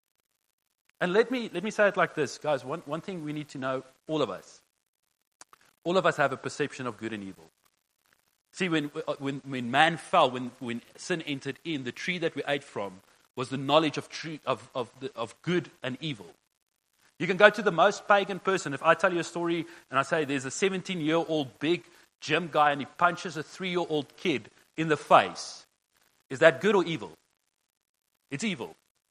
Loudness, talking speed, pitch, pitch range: -28 LUFS, 210 wpm, 155 Hz, 135-175 Hz